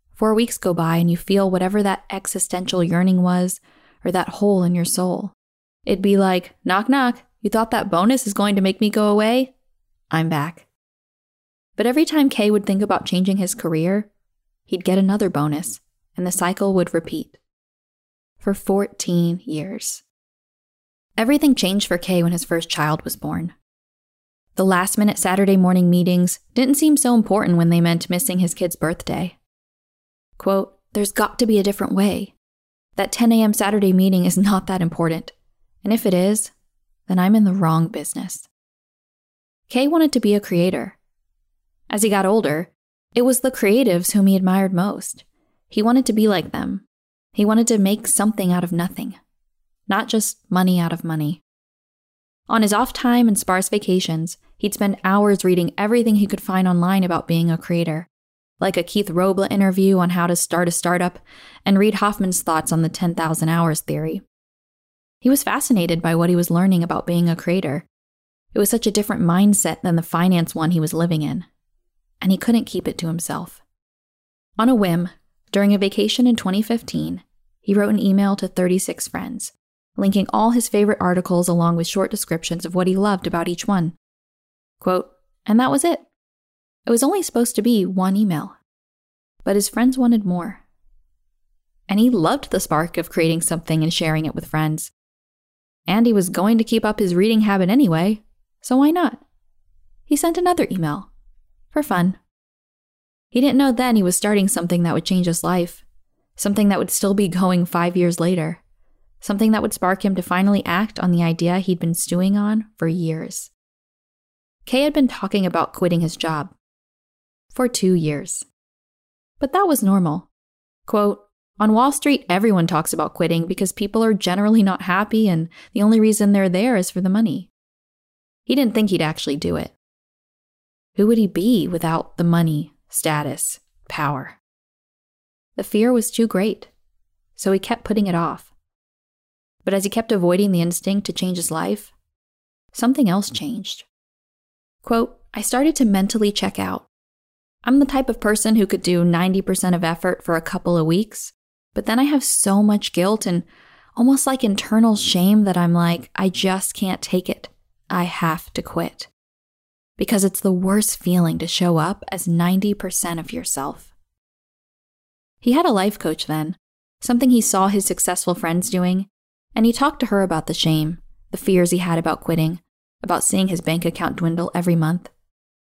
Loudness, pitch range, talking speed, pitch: -19 LUFS, 170-210 Hz, 175 wpm, 190 Hz